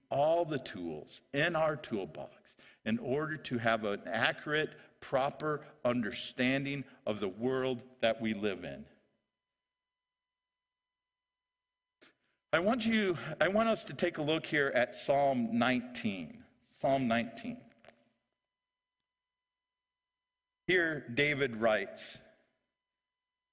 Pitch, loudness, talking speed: 160 Hz, -33 LUFS, 100 wpm